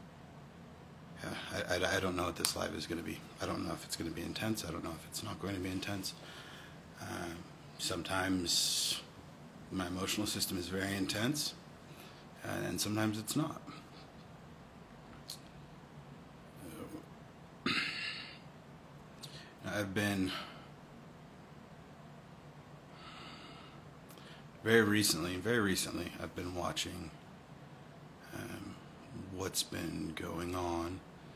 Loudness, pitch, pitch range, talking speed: -37 LUFS, 95 Hz, 90-105 Hz, 110 wpm